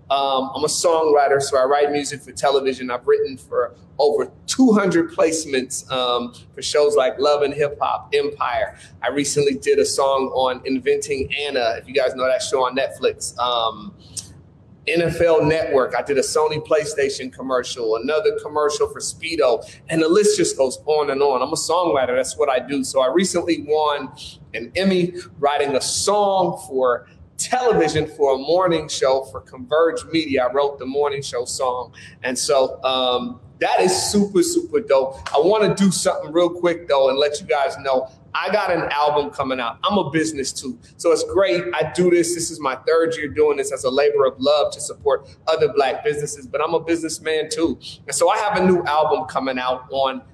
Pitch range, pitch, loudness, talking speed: 135-190 Hz, 155 Hz, -20 LUFS, 195 wpm